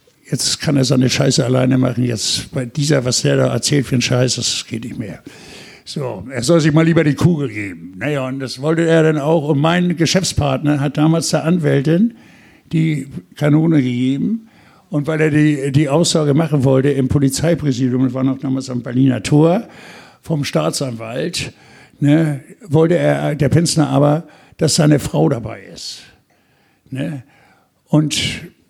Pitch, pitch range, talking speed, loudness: 145 Hz, 130-160 Hz, 165 wpm, -16 LUFS